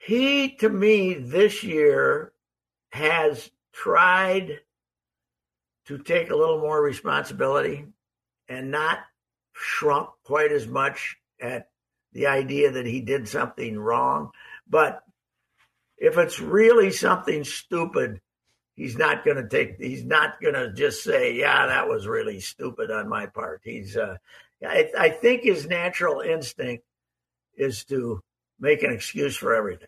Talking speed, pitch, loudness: 135 wpm, 190 Hz, -23 LUFS